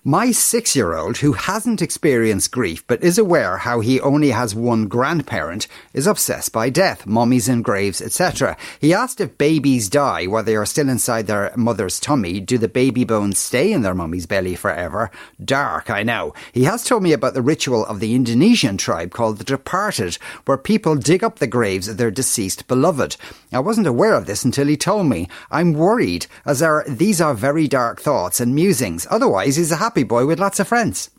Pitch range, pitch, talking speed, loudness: 115-160 Hz, 130 Hz, 200 wpm, -18 LUFS